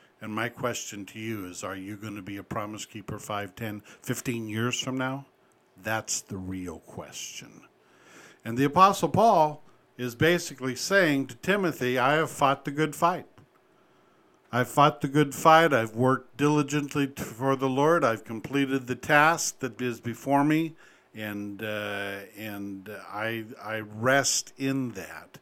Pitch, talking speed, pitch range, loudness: 125 Hz, 155 wpm, 105-145 Hz, -26 LUFS